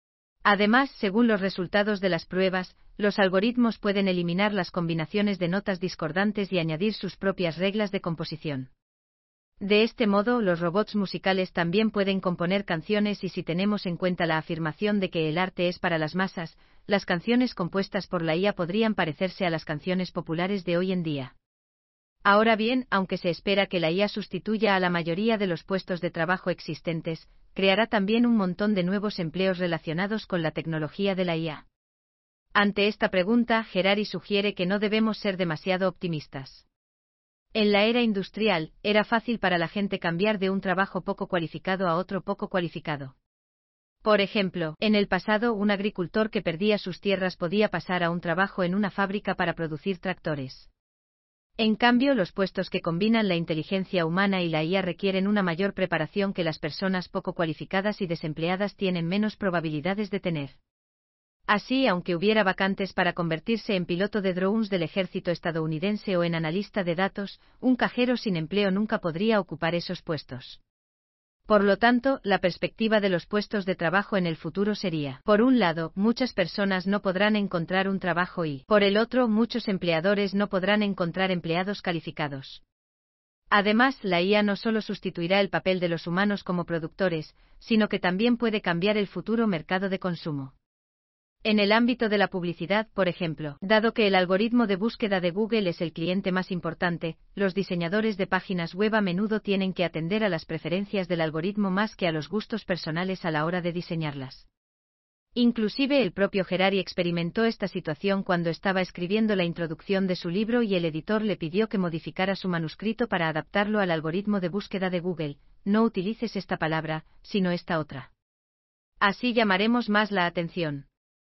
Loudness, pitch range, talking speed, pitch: -26 LUFS, 170-205 Hz, 175 wpm, 190 Hz